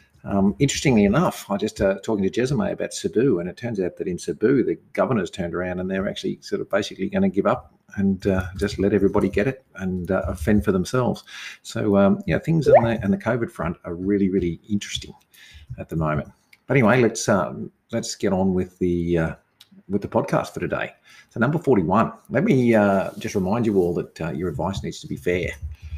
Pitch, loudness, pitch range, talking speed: 100 Hz, -22 LUFS, 90-115 Hz, 220 wpm